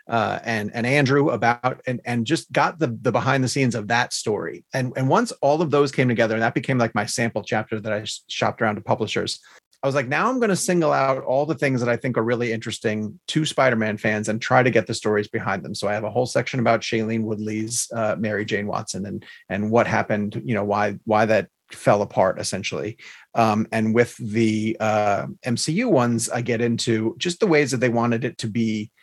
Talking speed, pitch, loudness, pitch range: 230 wpm, 115 Hz, -22 LUFS, 110-130 Hz